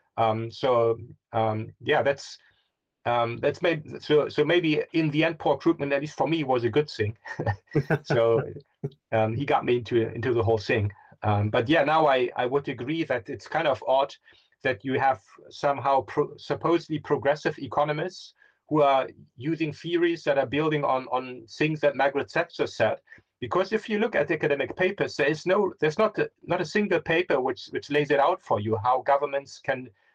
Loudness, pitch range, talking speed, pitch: -26 LUFS, 125-160 Hz, 190 wpm, 140 Hz